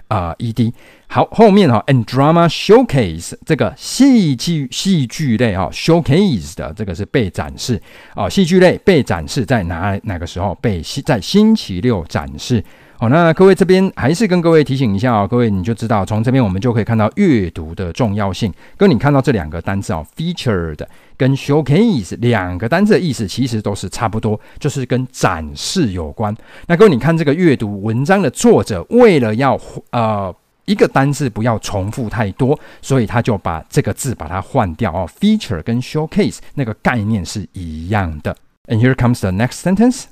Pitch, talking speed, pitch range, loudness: 120 Hz, 375 characters per minute, 100-155 Hz, -15 LUFS